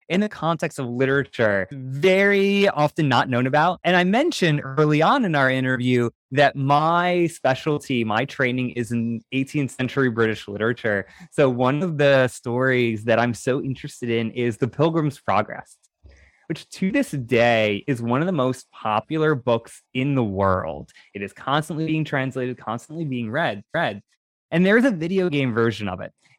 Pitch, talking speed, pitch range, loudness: 135 Hz, 170 wpm, 120-160 Hz, -21 LUFS